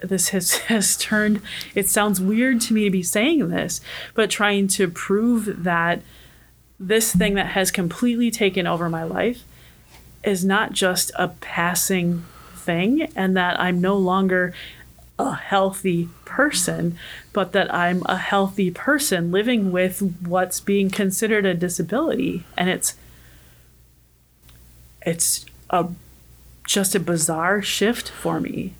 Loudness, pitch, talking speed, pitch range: -21 LUFS, 190 Hz, 135 wpm, 170-205 Hz